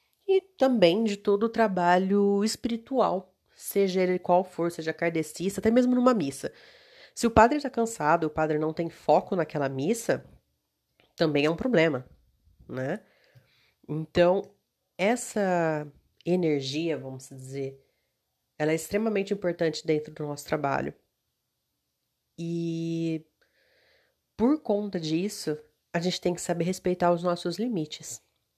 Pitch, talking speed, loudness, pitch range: 175 Hz, 125 wpm, -27 LUFS, 155-205 Hz